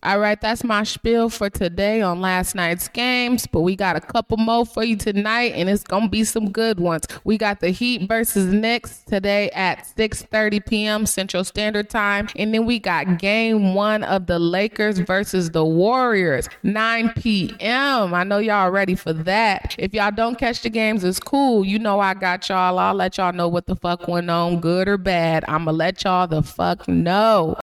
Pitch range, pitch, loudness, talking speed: 180-220 Hz, 200 Hz, -20 LUFS, 200 wpm